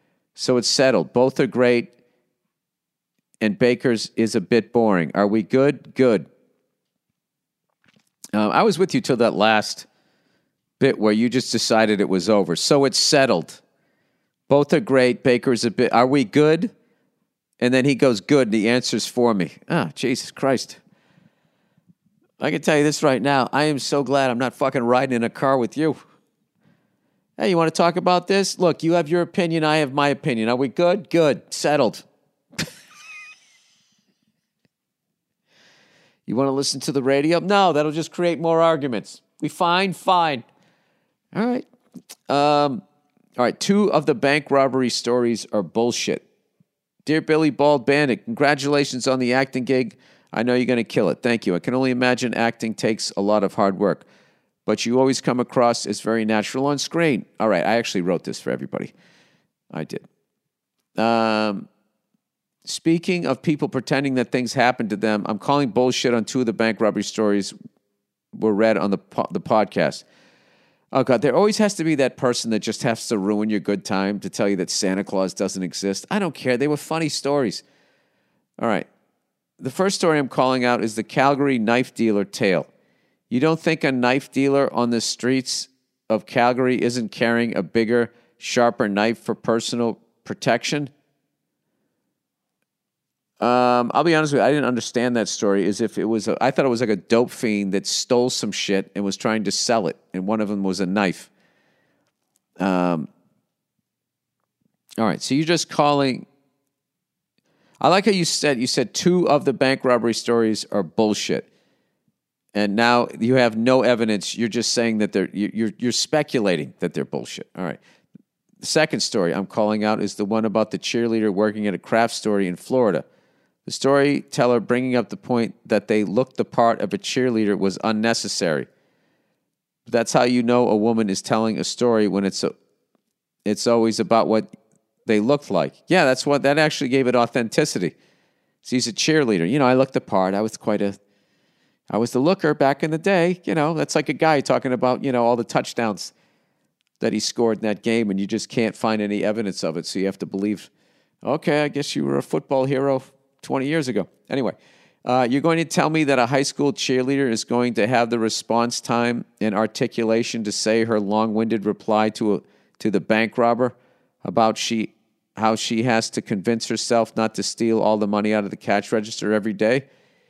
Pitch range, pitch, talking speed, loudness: 110-140 Hz, 120 Hz, 190 wpm, -21 LUFS